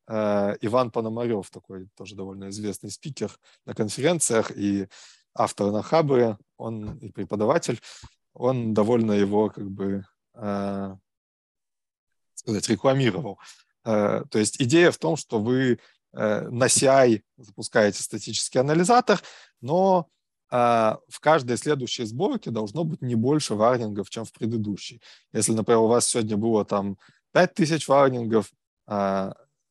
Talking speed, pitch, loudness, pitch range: 115 wpm, 110 Hz, -24 LUFS, 100-130 Hz